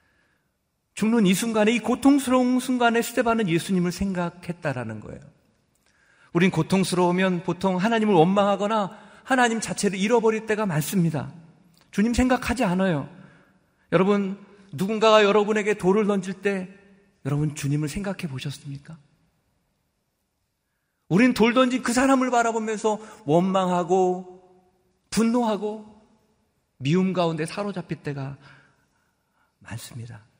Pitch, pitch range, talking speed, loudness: 195 Hz, 170-220 Hz, 285 characters per minute, -23 LUFS